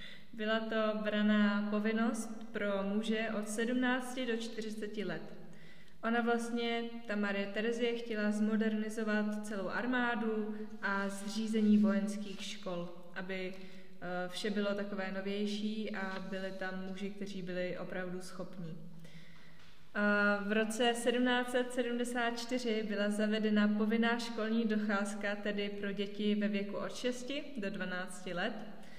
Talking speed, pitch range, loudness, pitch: 115 wpm, 195-225 Hz, -35 LUFS, 210 Hz